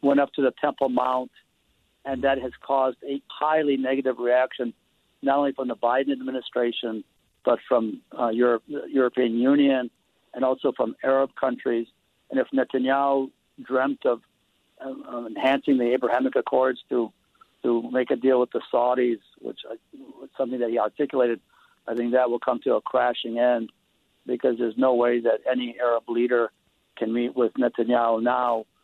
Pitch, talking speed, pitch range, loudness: 125 Hz, 165 wpm, 120-135 Hz, -24 LUFS